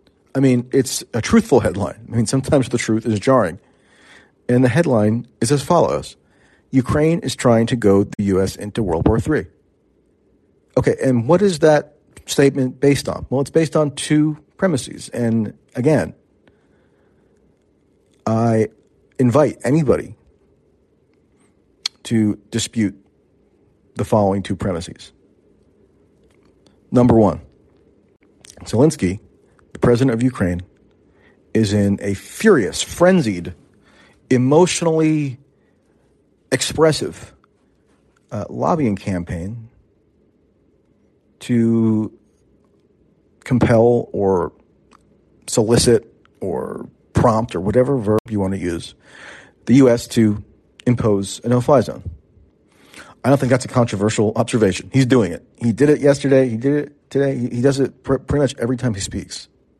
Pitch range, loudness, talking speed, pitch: 105-135 Hz, -18 LUFS, 120 wpm, 120 Hz